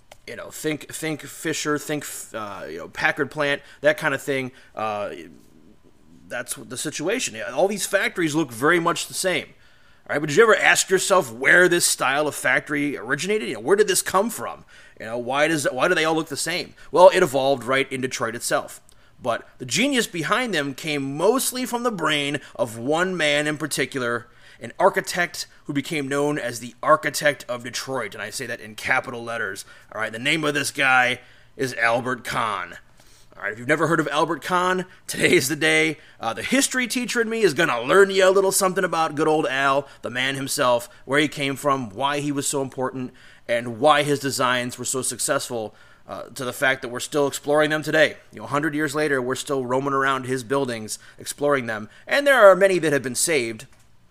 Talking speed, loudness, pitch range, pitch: 210 wpm, -22 LUFS, 130-170 Hz, 145 Hz